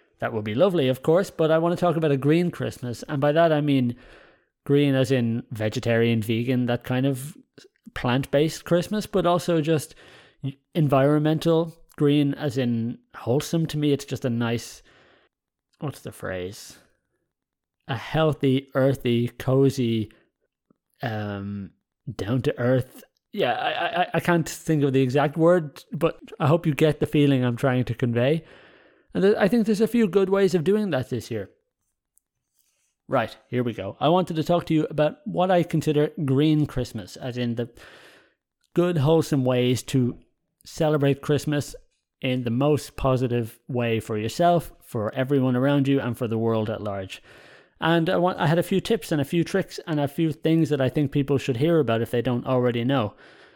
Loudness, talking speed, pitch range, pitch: -23 LUFS, 175 wpm, 120-160 Hz, 140 Hz